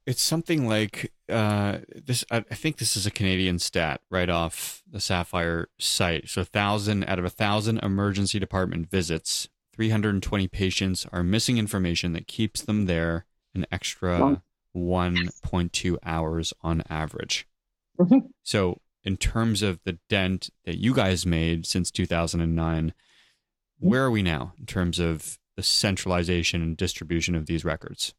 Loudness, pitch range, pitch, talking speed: -26 LUFS, 85-105 Hz, 95 Hz, 160 wpm